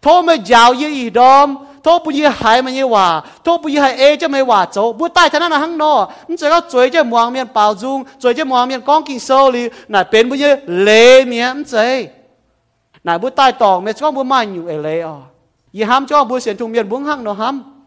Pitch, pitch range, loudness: 255 Hz, 220-290 Hz, -12 LUFS